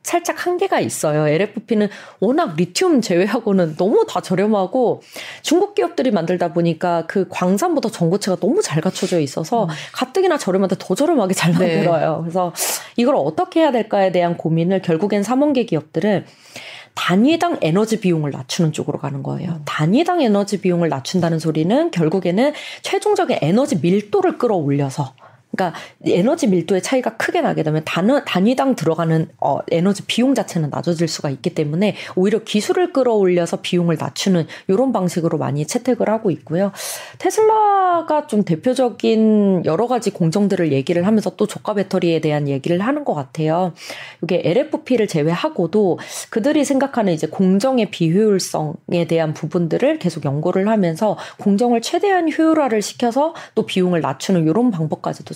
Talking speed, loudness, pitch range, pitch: 375 characters per minute, -18 LUFS, 170-245 Hz, 195 Hz